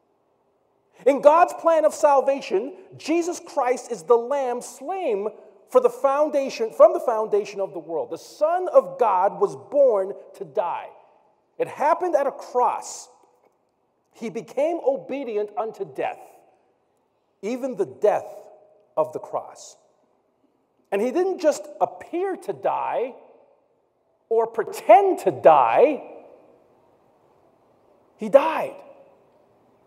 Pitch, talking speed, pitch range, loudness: 275 Hz, 115 wpm, 225-340 Hz, -22 LUFS